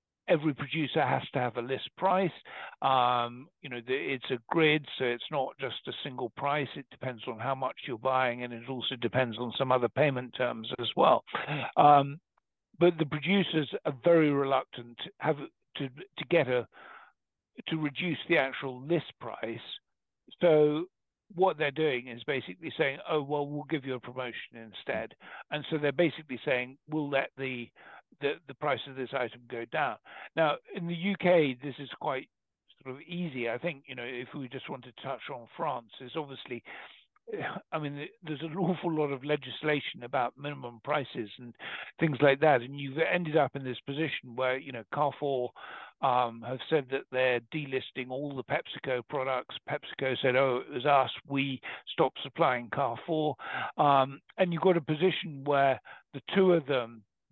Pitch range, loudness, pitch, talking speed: 125-155 Hz, -31 LUFS, 140 Hz, 180 wpm